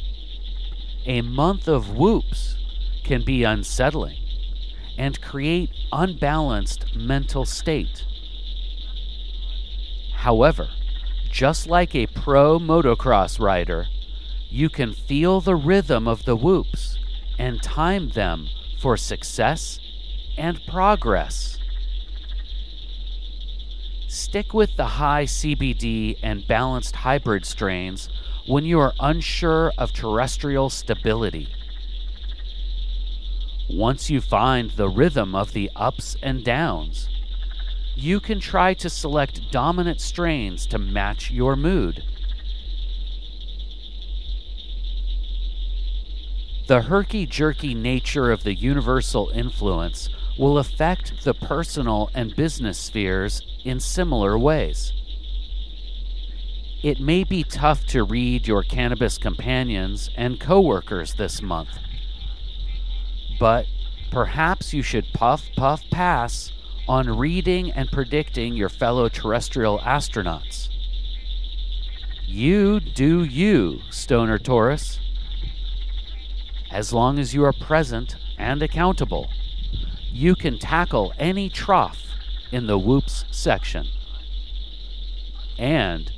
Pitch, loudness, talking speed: 105 Hz, -23 LUFS, 95 wpm